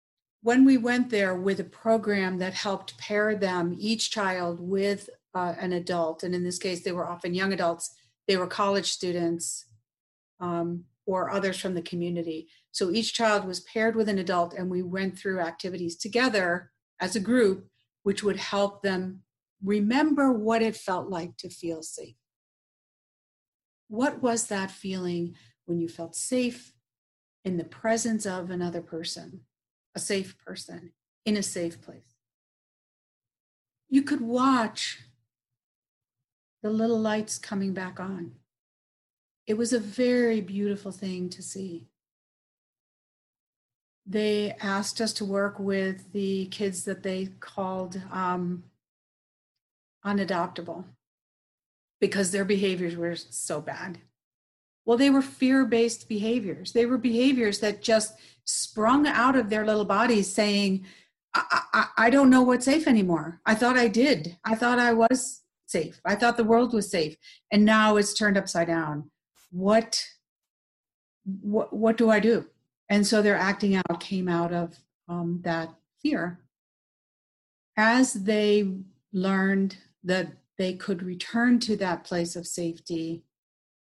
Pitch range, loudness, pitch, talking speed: 175-220 Hz, -26 LUFS, 195 Hz, 140 wpm